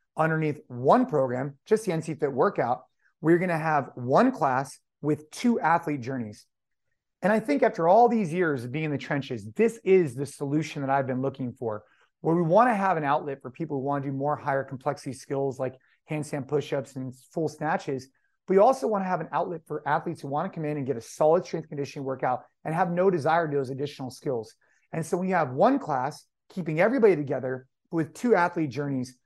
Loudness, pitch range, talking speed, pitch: -27 LUFS, 135-170 Hz, 220 wpm, 150 Hz